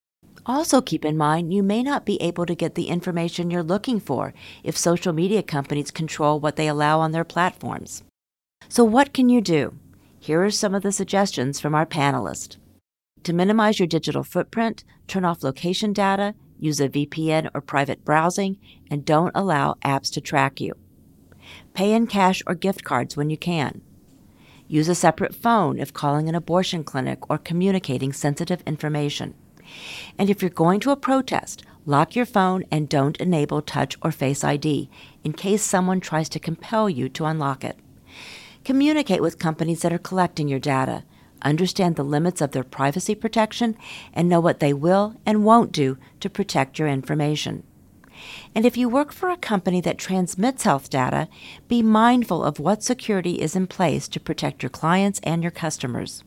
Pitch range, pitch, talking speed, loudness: 150-195 Hz, 170 Hz, 175 wpm, -22 LUFS